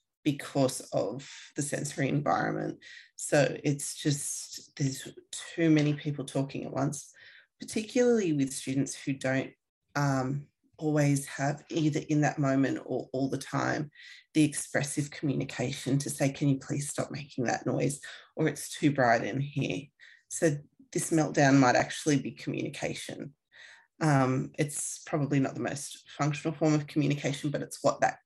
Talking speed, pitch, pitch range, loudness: 150 wpm, 145 Hz, 135-155 Hz, -30 LUFS